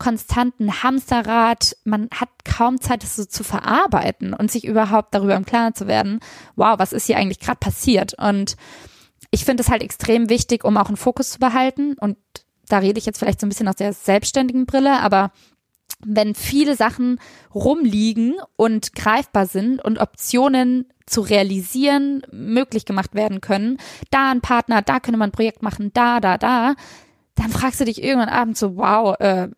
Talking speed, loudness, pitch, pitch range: 180 wpm, -19 LUFS, 225 Hz, 210-255 Hz